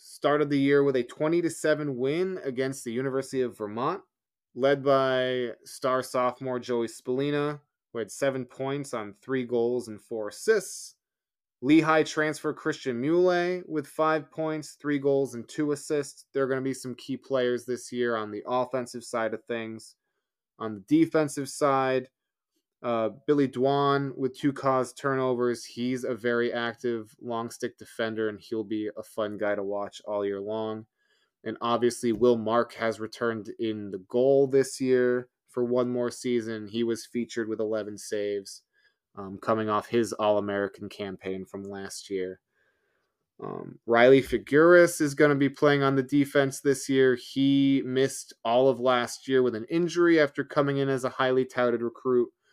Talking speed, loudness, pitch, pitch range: 170 wpm, -27 LUFS, 125 Hz, 115-140 Hz